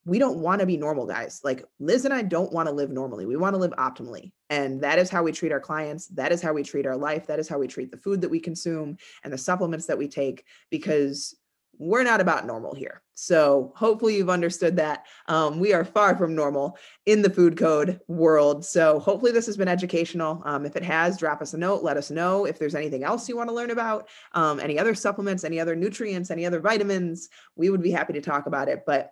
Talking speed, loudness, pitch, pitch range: 245 wpm, -25 LUFS, 165 Hz, 150-190 Hz